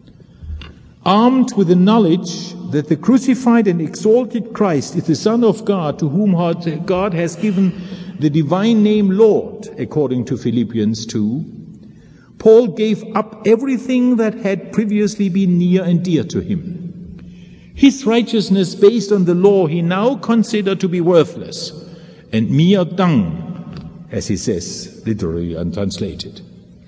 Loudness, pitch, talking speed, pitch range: -16 LUFS, 185 Hz, 140 wpm, 165-215 Hz